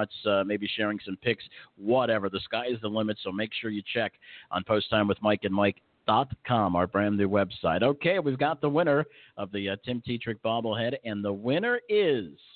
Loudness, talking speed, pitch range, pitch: -28 LUFS, 200 wpm, 100-125 Hz, 105 Hz